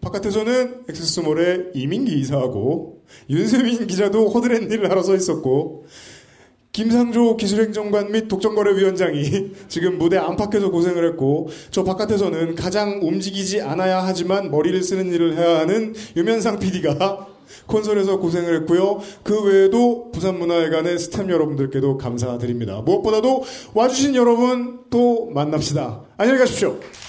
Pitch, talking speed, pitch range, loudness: 190 Hz, 350 characters per minute, 165-215 Hz, -19 LUFS